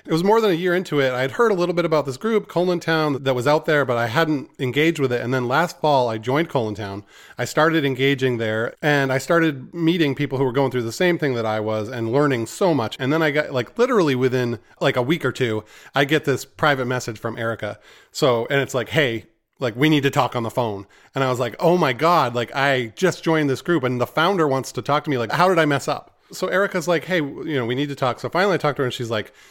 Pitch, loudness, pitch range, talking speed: 140 Hz, -21 LUFS, 125-160 Hz, 280 wpm